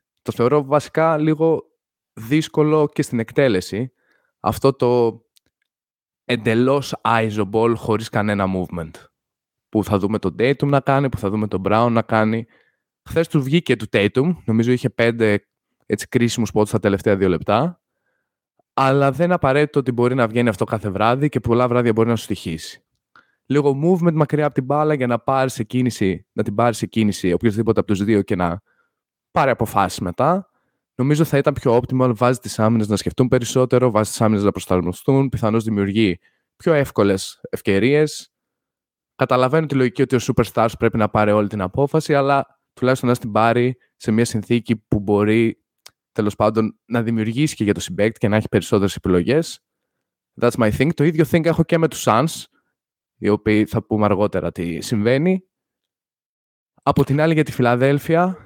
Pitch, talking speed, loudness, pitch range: 120 Hz, 170 wpm, -19 LUFS, 105-140 Hz